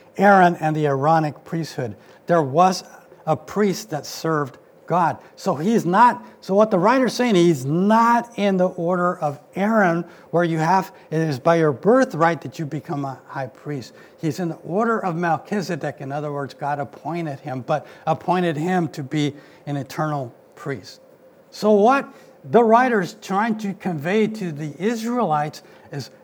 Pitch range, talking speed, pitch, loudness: 150-200 Hz, 165 wpm, 170 Hz, -21 LUFS